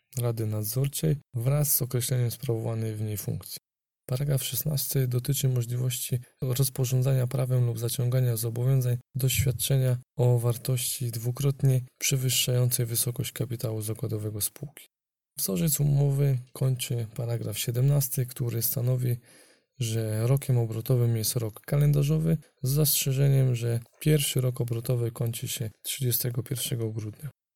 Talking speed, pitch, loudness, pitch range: 110 wpm, 125 Hz, -27 LUFS, 120-135 Hz